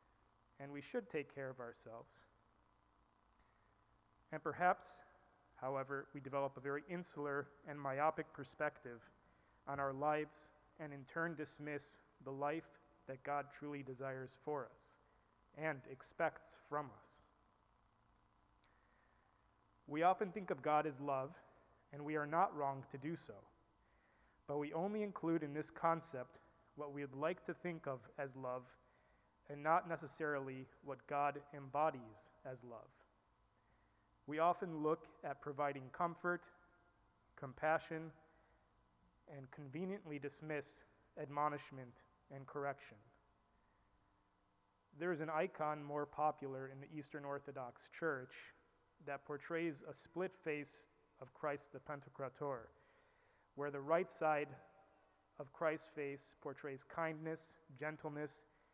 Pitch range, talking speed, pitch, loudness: 130-155 Hz, 120 wpm, 145 Hz, -44 LUFS